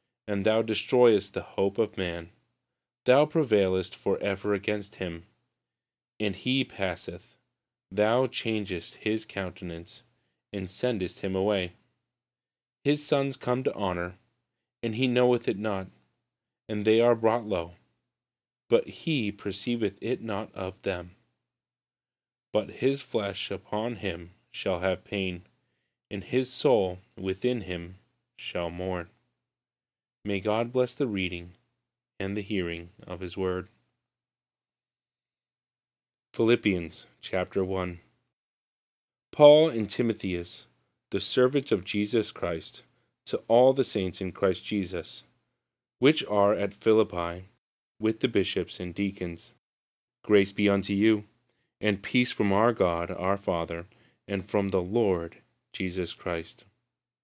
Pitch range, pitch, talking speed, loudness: 95-120 Hz, 100 Hz, 120 wpm, -28 LUFS